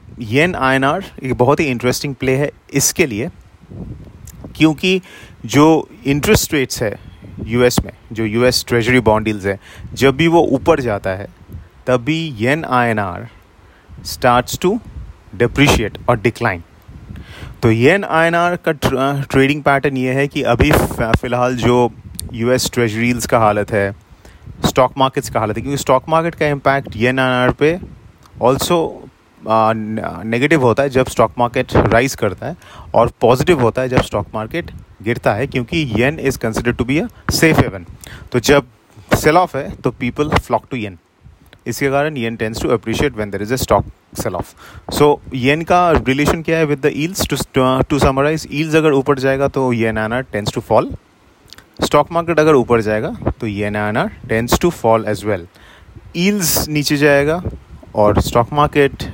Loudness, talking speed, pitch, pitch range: -16 LUFS, 175 wpm, 125 Hz, 110-140 Hz